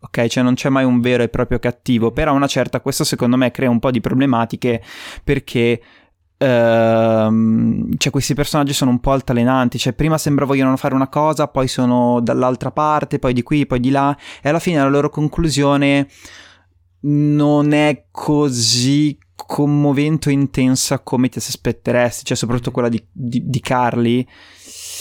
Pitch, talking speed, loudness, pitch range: 130 Hz, 165 wpm, -16 LUFS, 120-145 Hz